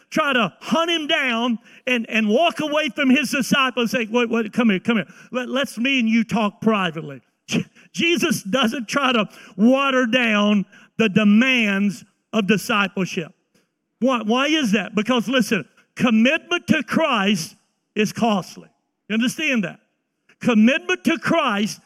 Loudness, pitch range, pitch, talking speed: -20 LUFS, 210-255 Hz, 230 Hz, 145 wpm